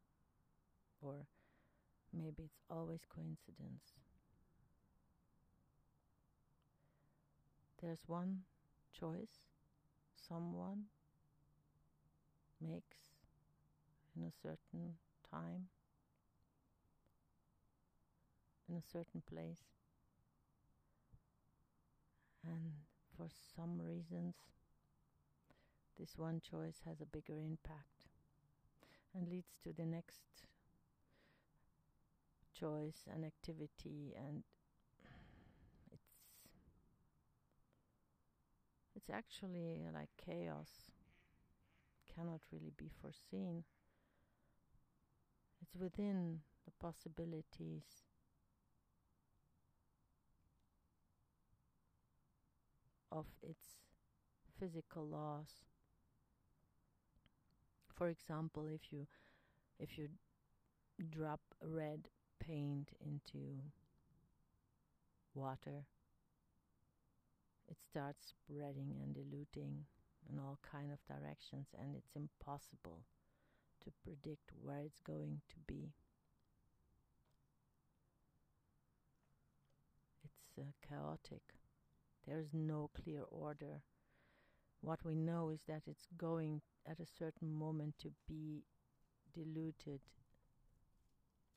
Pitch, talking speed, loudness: 150 Hz, 70 wpm, -51 LUFS